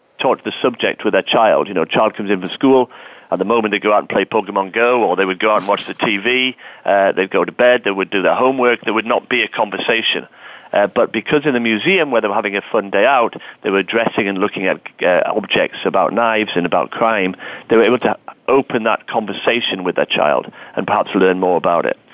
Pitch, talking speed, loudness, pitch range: 110 Hz, 250 wpm, -16 LUFS, 95-120 Hz